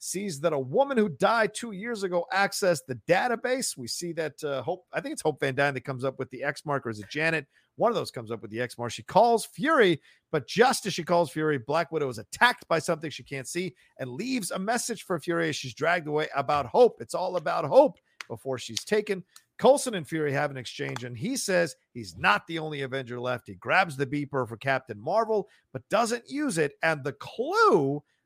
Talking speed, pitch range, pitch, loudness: 230 wpm, 135-205 Hz, 160 Hz, -27 LUFS